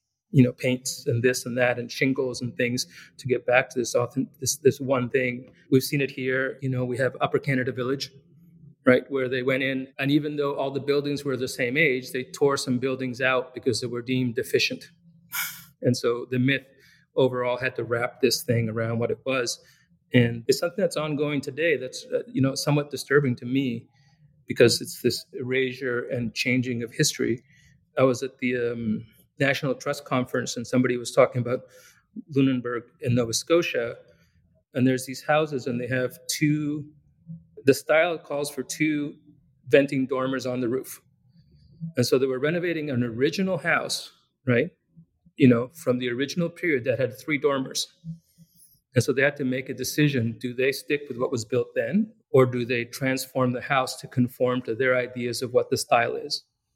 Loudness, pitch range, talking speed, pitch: -25 LUFS, 125-150 Hz, 190 wpm, 130 Hz